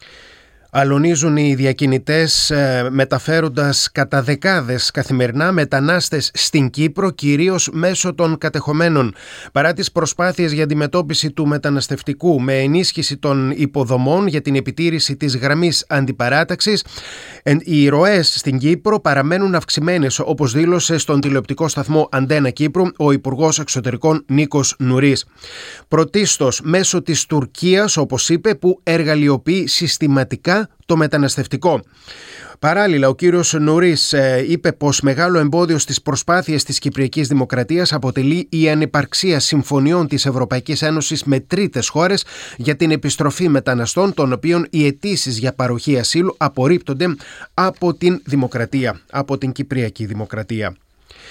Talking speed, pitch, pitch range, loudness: 120 wpm, 150 Hz, 135-170 Hz, -16 LUFS